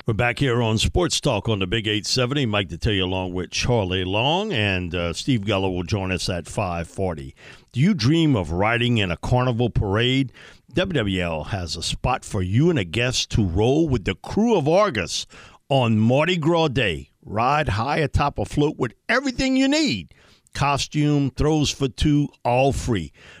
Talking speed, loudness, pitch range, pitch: 180 wpm, -22 LUFS, 95-140 Hz, 120 Hz